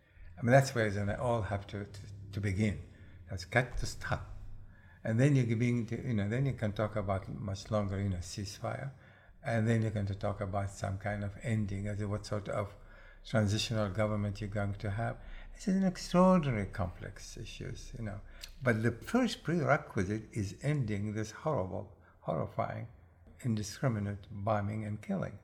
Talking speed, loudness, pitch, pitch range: 175 wpm, -34 LUFS, 105 Hz, 100-120 Hz